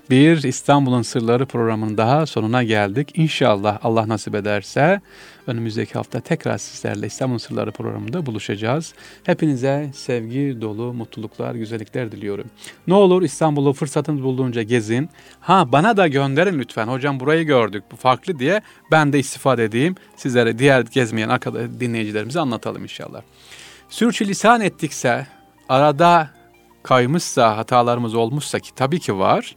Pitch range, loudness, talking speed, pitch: 115-150 Hz, -19 LUFS, 130 wpm, 130 Hz